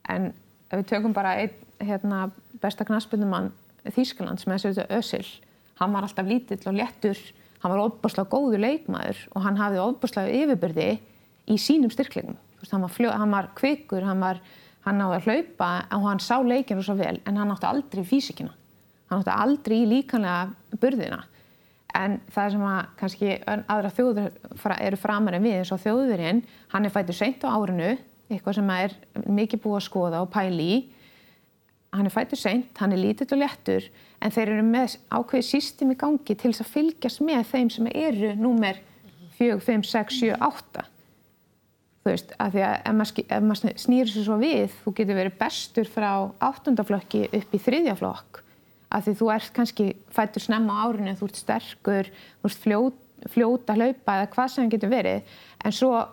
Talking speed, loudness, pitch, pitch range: 180 wpm, -25 LUFS, 215 Hz, 195-240 Hz